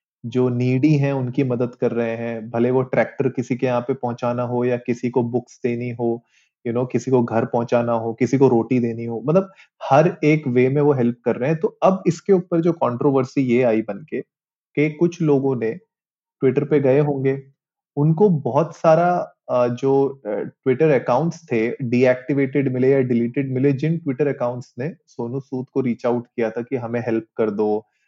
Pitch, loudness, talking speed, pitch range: 130 Hz, -20 LUFS, 200 wpm, 120-145 Hz